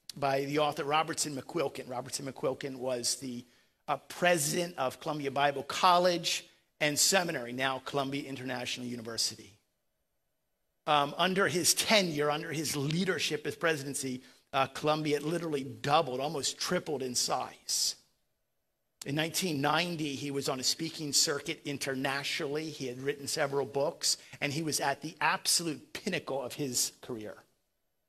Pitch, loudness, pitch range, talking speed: 145 Hz, -31 LUFS, 135-160 Hz, 130 wpm